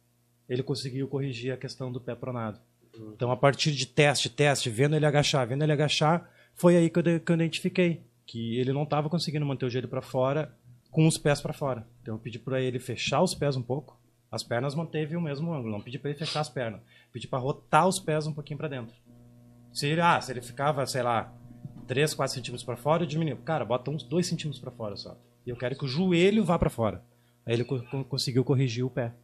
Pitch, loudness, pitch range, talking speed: 135 Hz, -28 LUFS, 120-155 Hz, 235 wpm